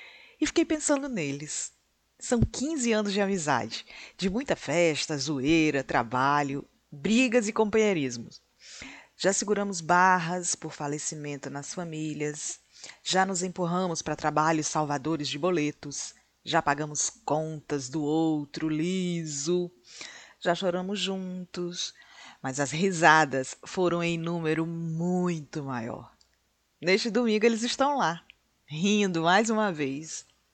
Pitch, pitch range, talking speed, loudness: 165 Hz, 150-190 Hz, 115 wpm, -28 LUFS